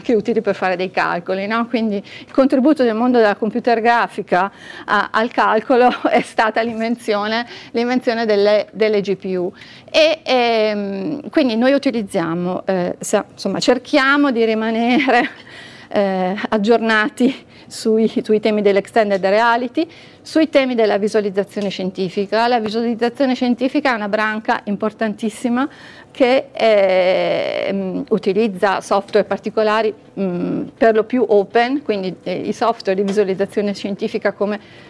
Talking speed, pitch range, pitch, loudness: 120 wpm, 205-245 Hz, 220 Hz, -17 LUFS